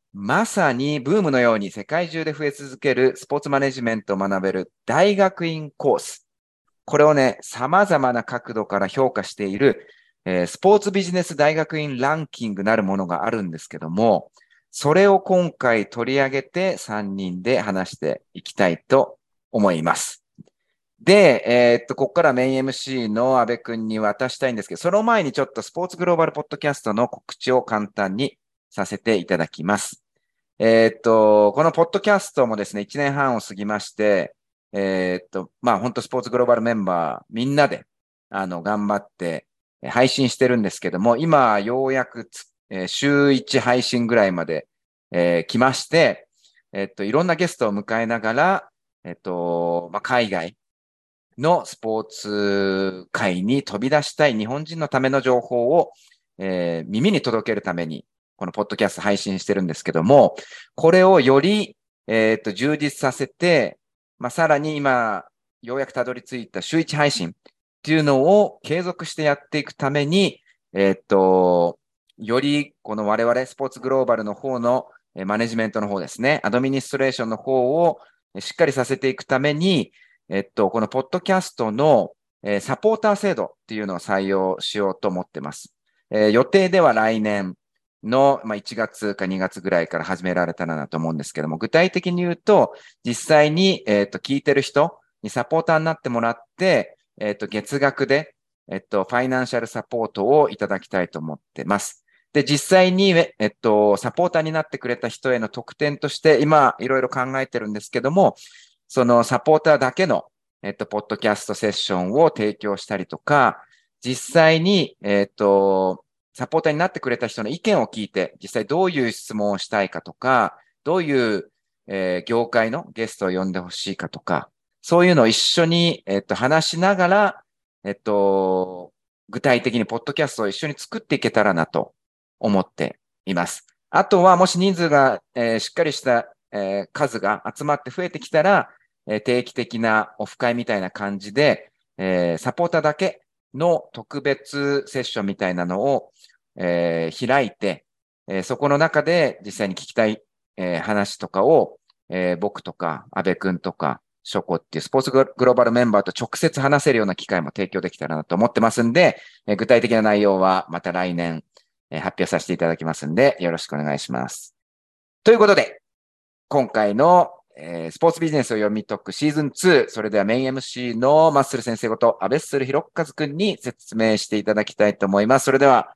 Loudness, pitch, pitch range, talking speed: -20 LUFS, 120 Hz, 100-145 Hz, 355 characters per minute